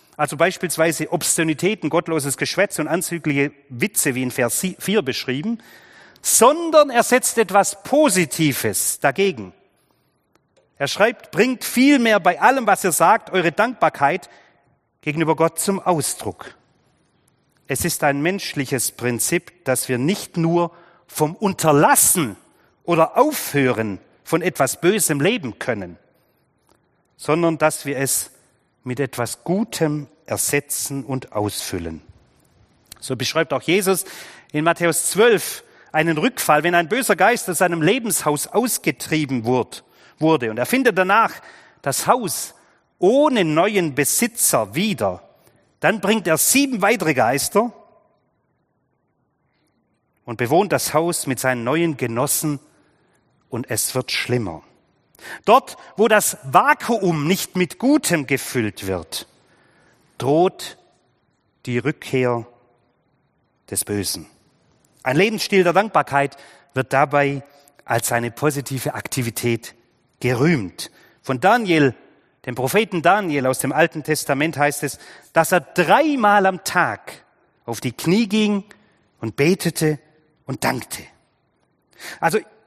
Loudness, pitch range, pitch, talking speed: -19 LUFS, 130-185 Hz, 155 Hz, 115 wpm